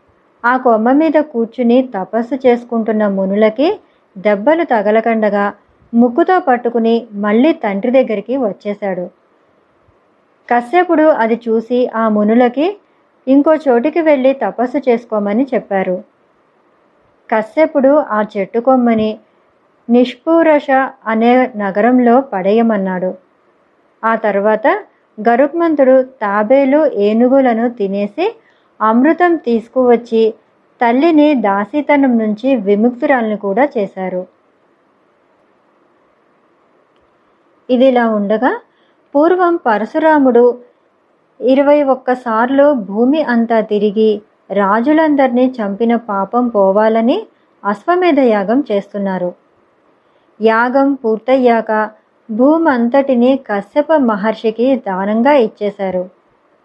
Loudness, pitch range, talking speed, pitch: -13 LUFS, 215-275 Hz, 75 wpm, 240 Hz